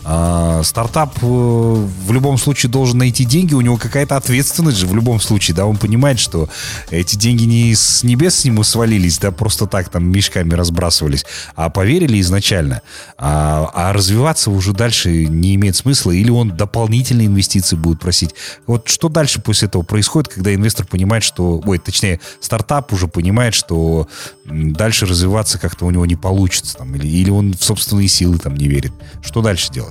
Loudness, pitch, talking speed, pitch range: -14 LUFS, 100 Hz, 175 wpm, 90-115 Hz